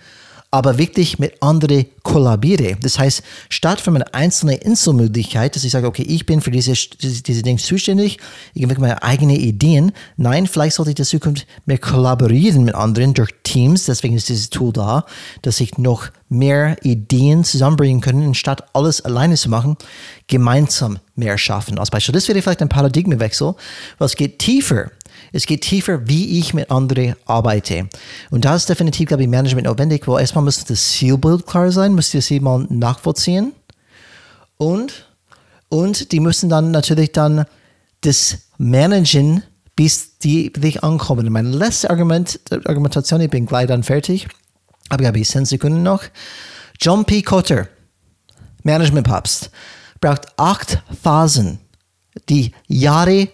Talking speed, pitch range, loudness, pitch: 150 wpm, 125-160 Hz, -15 LUFS, 140 Hz